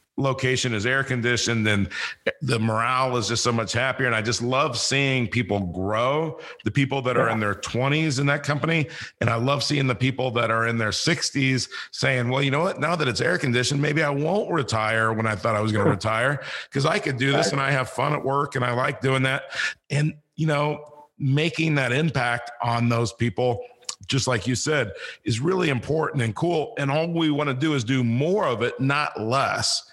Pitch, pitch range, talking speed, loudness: 130 Hz, 120-145 Hz, 220 wpm, -23 LUFS